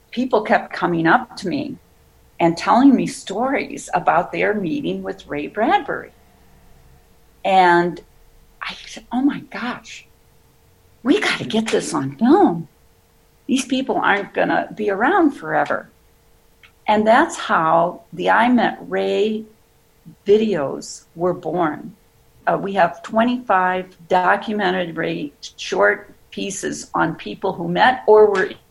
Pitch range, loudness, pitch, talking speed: 165-225 Hz, -19 LUFS, 190 Hz, 130 wpm